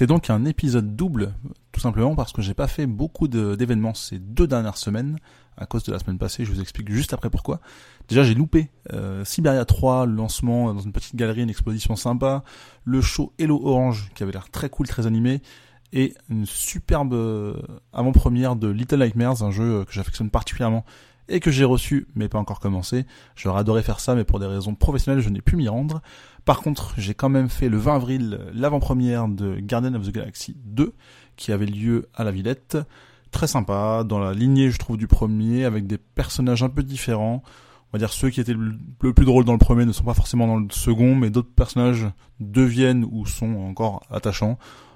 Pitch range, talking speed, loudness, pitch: 105-130 Hz, 205 wpm, -22 LUFS, 120 Hz